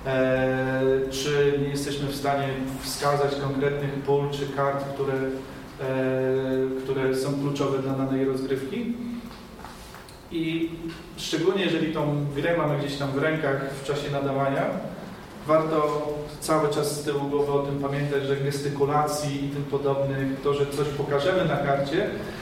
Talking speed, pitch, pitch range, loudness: 135 wpm, 140 Hz, 135-150 Hz, -26 LUFS